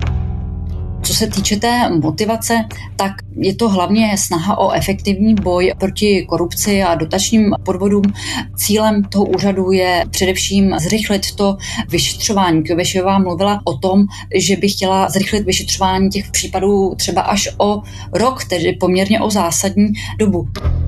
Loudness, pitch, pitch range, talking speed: -15 LUFS, 190 Hz, 170-200 Hz, 130 wpm